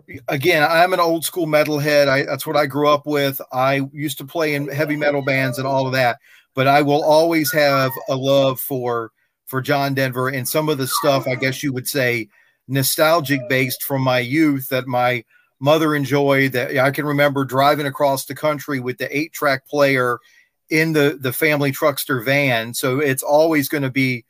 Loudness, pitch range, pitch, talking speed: -18 LUFS, 130-150 Hz, 140 Hz, 200 wpm